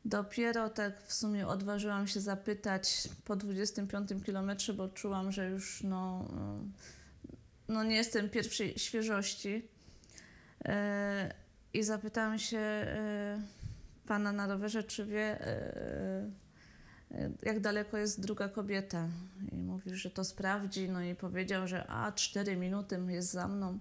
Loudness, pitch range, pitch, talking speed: -37 LUFS, 190-210 Hz, 200 Hz, 120 wpm